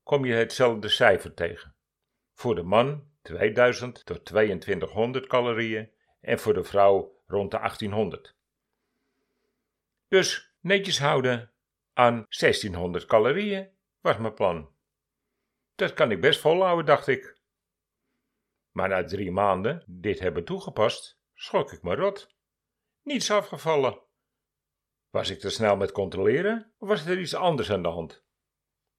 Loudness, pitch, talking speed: -25 LUFS, 125 Hz, 130 wpm